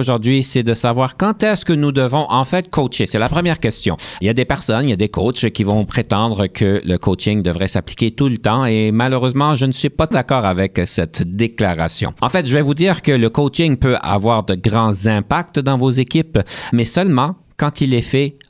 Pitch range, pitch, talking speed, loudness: 110-145 Hz, 125 Hz, 225 wpm, -16 LUFS